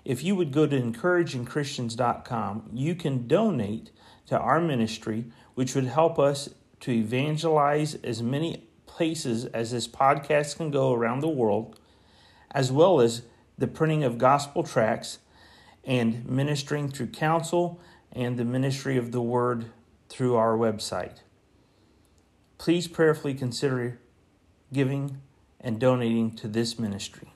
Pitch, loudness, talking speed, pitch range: 125 Hz, -26 LUFS, 130 wpm, 115-145 Hz